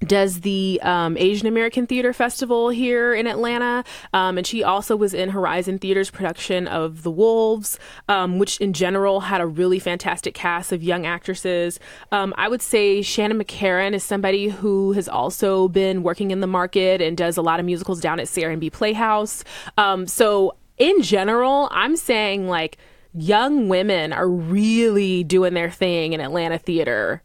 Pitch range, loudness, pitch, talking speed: 180-215 Hz, -20 LUFS, 195 Hz, 170 wpm